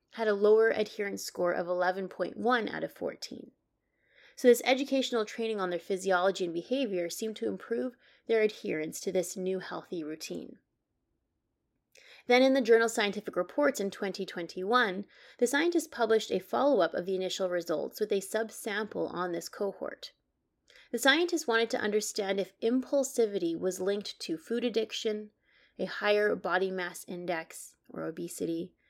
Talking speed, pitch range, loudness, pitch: 150 wpm, 185-235 Hz, -30 LUFS, 210 Hz